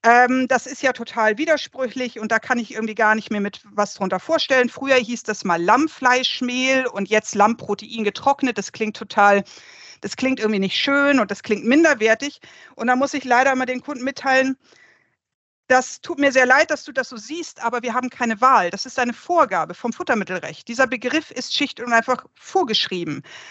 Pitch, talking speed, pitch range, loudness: 250 Hz, 195 wpm, 220-265 Hz, -20 LUFS